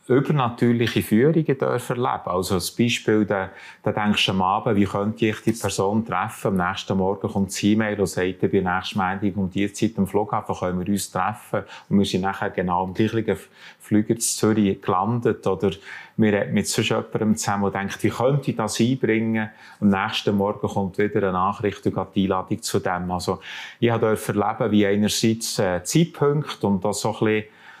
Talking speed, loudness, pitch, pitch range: 195 wpm, -22 LUFS, 105 Hz, 95-110 Hz